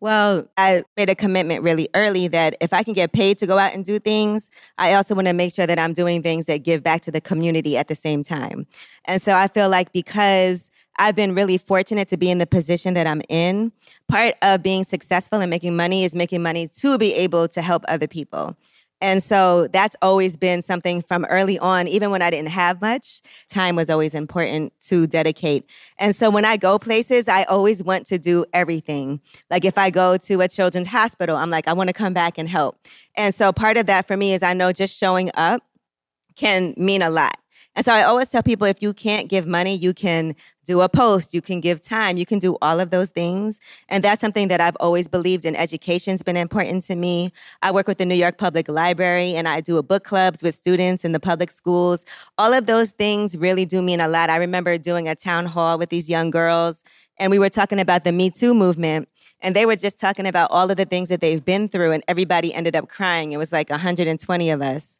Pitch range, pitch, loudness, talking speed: 170-195 Hz, 180 Hz, -19 LUFS, 235 wpm